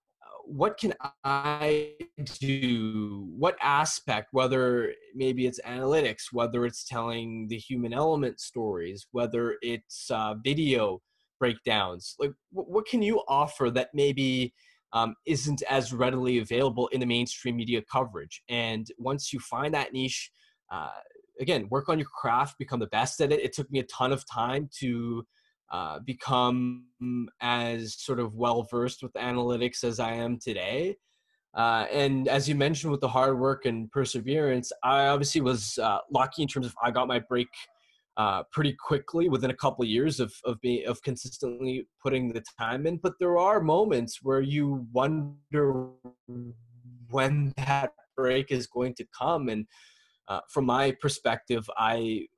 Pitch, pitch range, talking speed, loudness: 130 Hz, 120-140 Hz, 155 wpm, -29 LUFS